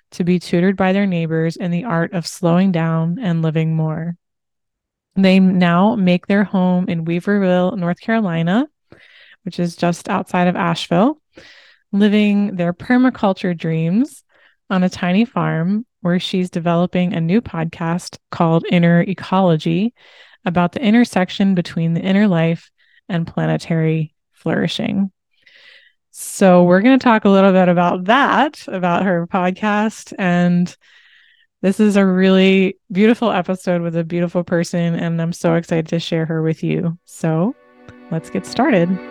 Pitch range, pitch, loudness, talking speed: 170-200 Hz, 180 Hz, -17 LUFS, 145 wpm